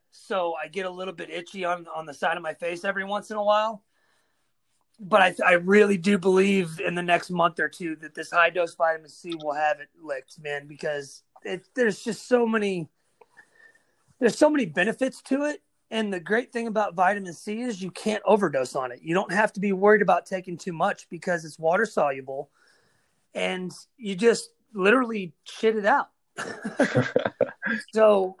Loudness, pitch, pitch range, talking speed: -25 LUFS, 190 Hz, 170-215 Hz, 190 wpm